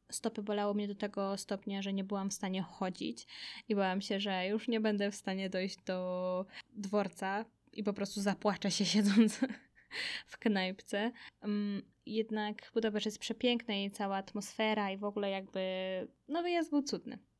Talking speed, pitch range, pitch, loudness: 160 wpm, 195-220 Hz, 205 Hz, -36 LUFS